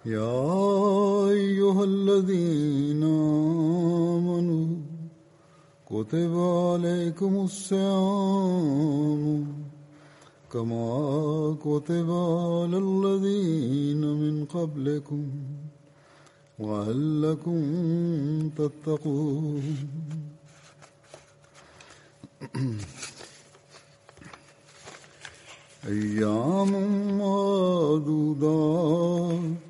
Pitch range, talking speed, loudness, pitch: 145-175 Hz, 35 wpm, -26 LUFS, 155 Hz